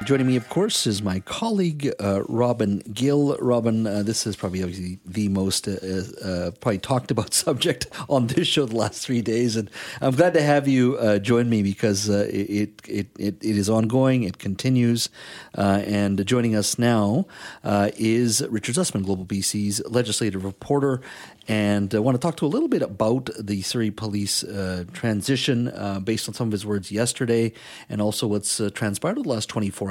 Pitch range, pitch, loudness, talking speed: 100-125 Hz, 110 Hz, -23 LUFS, 195 wpm